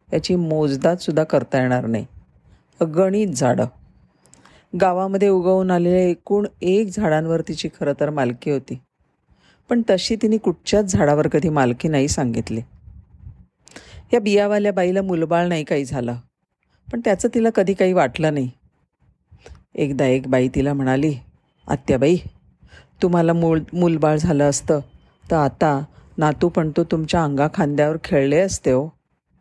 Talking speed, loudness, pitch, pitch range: 125 wpm, -19 LUFS, 160 Hz, 140-185 Hz